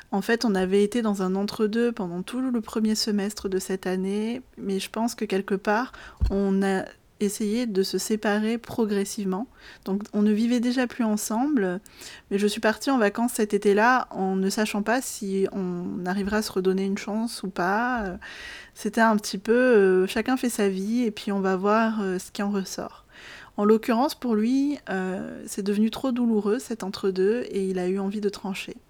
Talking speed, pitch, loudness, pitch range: 195 wpm, 210 Hz, -25 LUFS, 195-230 Hz